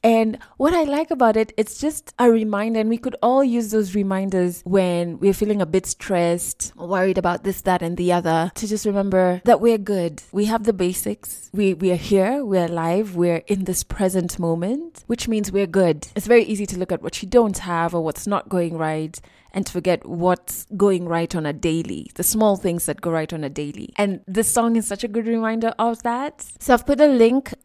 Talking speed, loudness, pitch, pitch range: 225 wpm, -21 LUFS, 195 Hz, 175-230 Hz